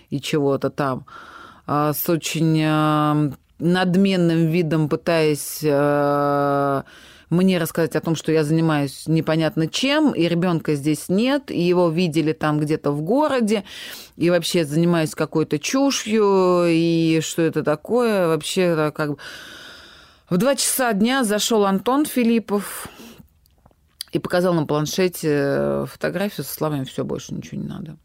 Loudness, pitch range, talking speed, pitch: -20 LUFS, 150-190 Hz, 125 wpm, 165 Hz